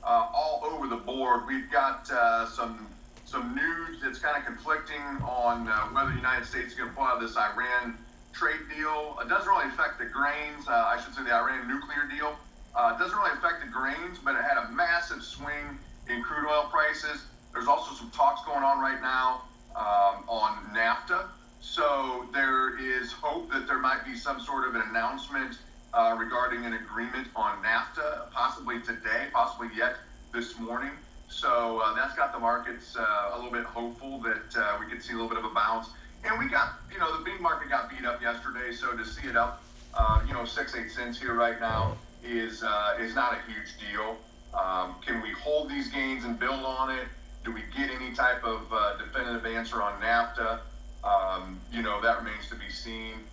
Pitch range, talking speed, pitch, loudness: 115-145 Hz, 205 wpm, 125 Hz, -29 LUFS